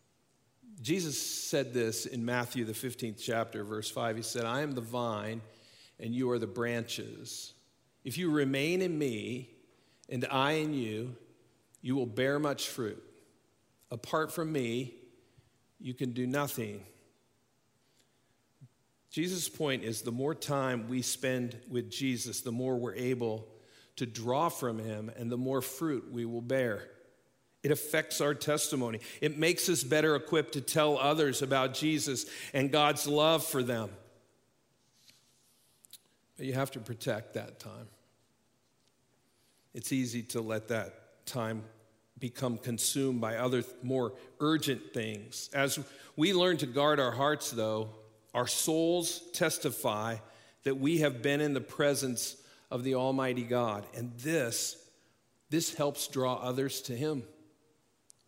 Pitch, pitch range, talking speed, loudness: 125 Hz, 120-145 Hz, 140 wpm, -33 LUFS